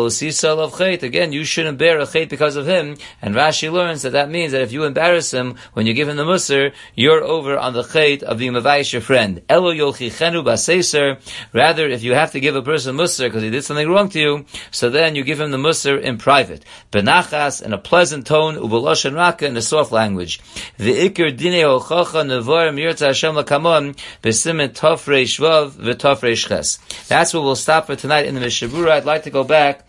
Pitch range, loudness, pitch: 130-160 Hz, -16 LUFS, 145 Hz